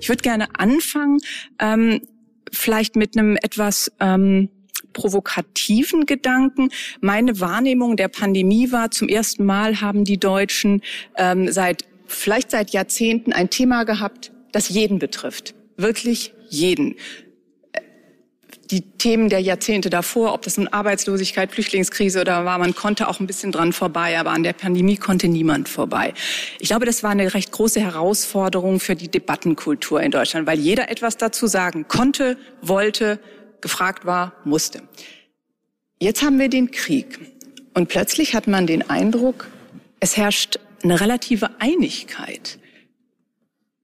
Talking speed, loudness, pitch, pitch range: 140 wpm, -19 LUFS, 210 Hz, 190-240 Hz